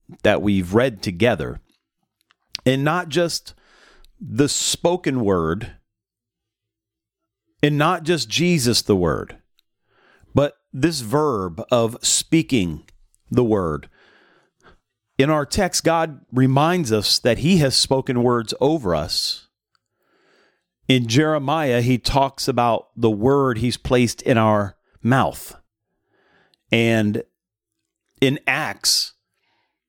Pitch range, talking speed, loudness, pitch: 110-150 Hz, 100 wpm, -19 LUFS, 125 Hz